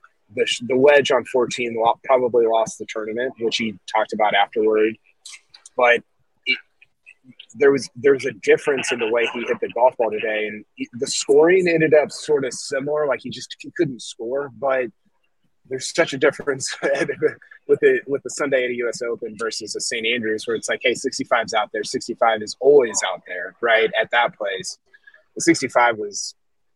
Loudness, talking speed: -20 LUFS, 180 wpm